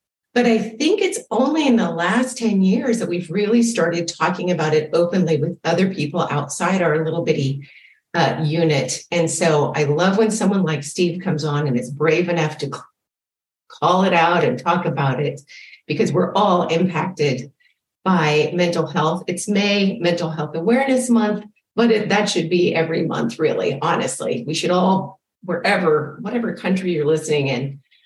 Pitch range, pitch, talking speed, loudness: 155-205 Hz, 175 Hz, 170 wpm, -19 LUFS